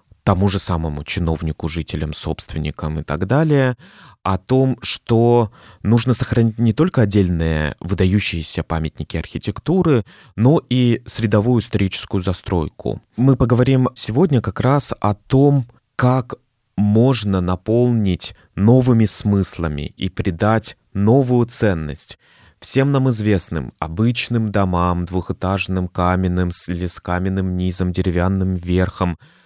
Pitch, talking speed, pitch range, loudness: 100 Hz, 110 wpm, 90-120 Hz, -18 LUFS